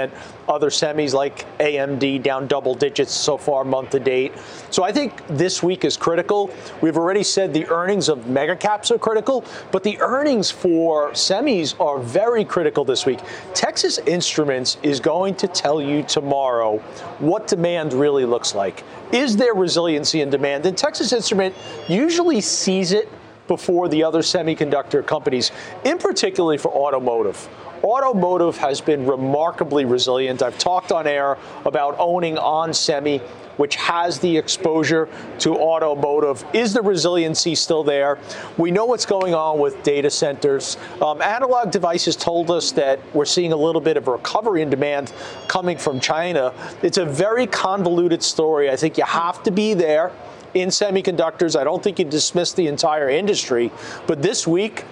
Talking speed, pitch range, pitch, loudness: 160 wpm, 145-190 Hz, 165 Hz, -19 LUFS